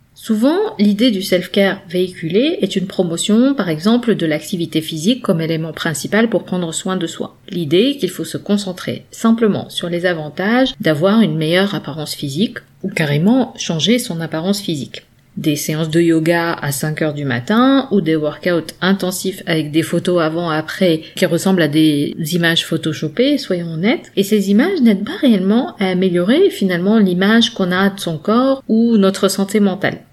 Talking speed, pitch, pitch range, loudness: 170 wpm, 185 Hz, 165-215 Hz, -16 LUFS